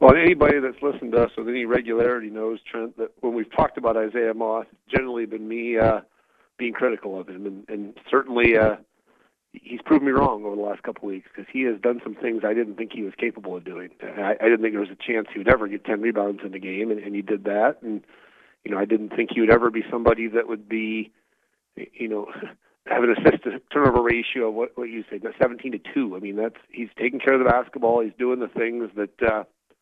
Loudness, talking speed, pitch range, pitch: -23 LUFS, 240 wpm, 105-120 Hz, 115 Hz